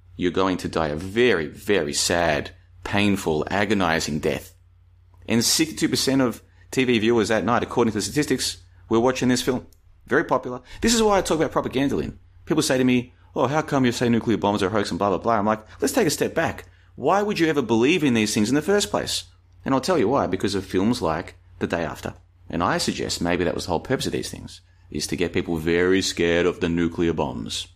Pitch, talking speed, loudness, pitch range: 95 Hz, 230 wpm, -22 LUFS, 90-125 Hz